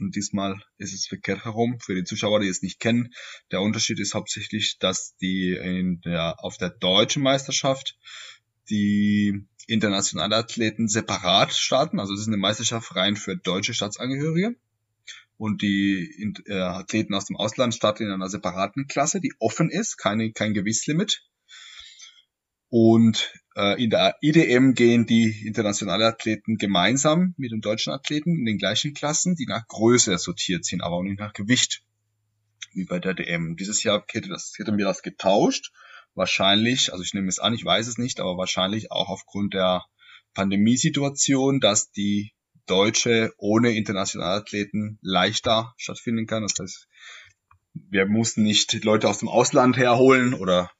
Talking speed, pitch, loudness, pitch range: 160 wpm, 110 Hz, -23 LUFS, 100-115 Hz